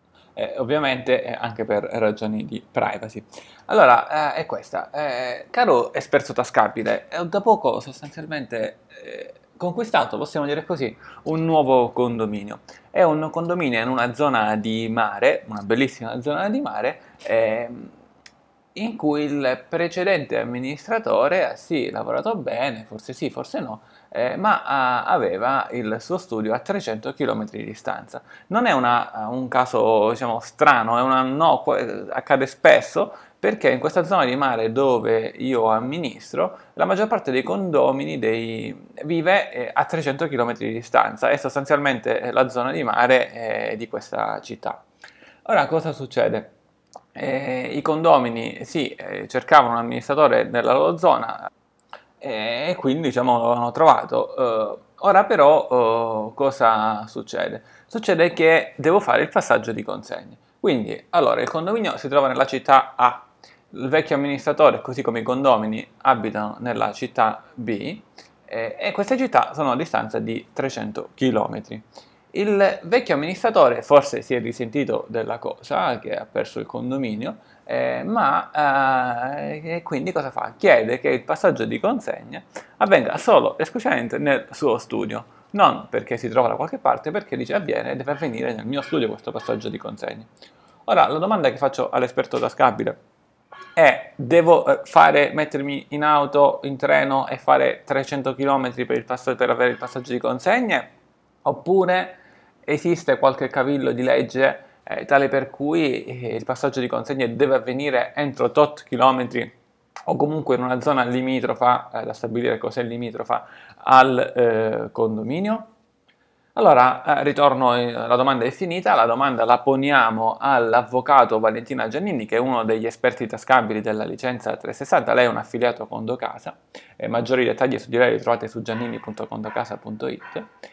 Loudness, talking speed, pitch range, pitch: -21 LUFS, 150 wpm, 120-155 Hz, 135 Hz